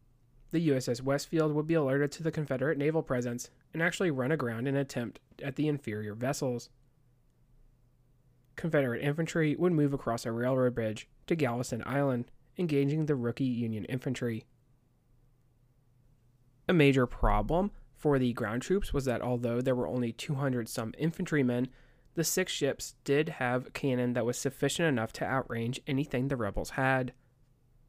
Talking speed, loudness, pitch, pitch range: 150 wpm, -31 LUFS, 130 Hz, 125-145 Hz